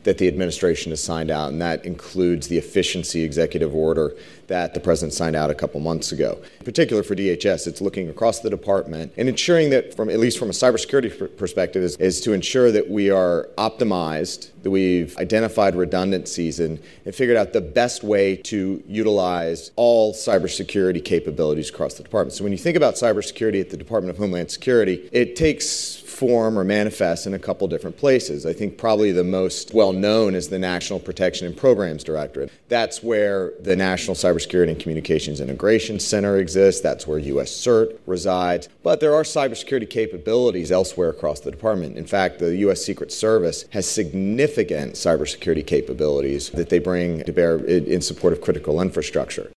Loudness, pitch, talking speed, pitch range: -21 LUFS, 95 Hz, 180 wpm, 85-105 Hz